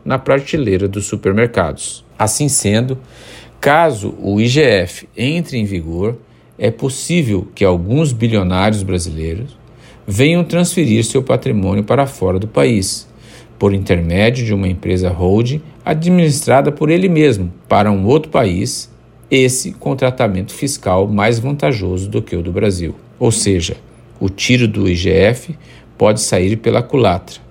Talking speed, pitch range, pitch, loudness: 135 wpm, 95-130 Hz, 110 Hz, -15 LUFS